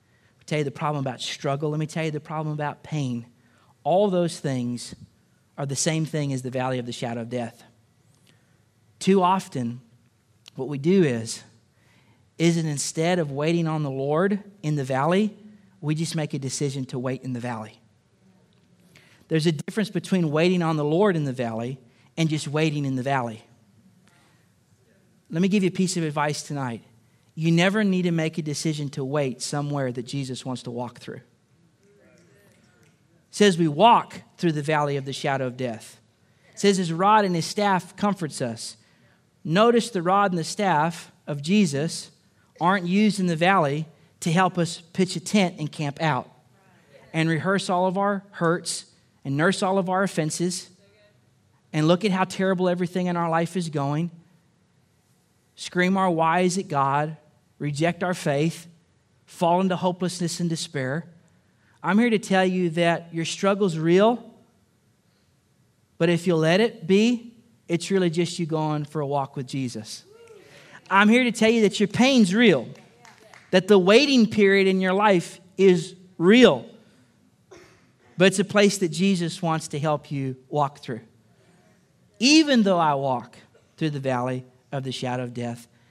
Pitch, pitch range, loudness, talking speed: 160 Hz, 135-185 Hz, -23 LUFS, 170 wpm